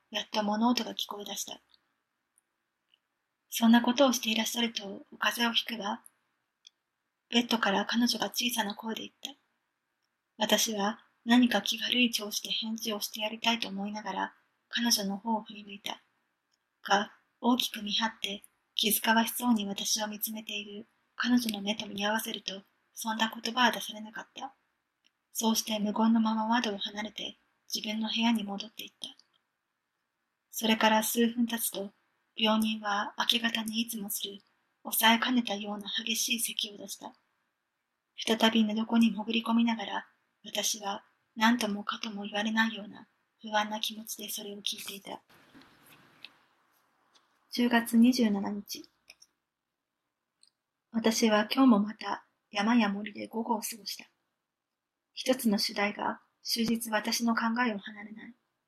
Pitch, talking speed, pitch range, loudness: 220 Hz, 280 characters per minute, 210-230 Hz, -30 LUFS